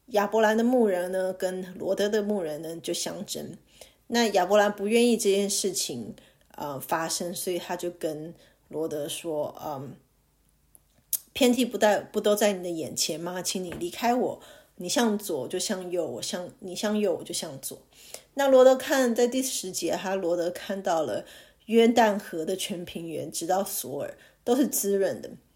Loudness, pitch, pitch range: -26 LUFS, 195 Hz, 175-220 Hz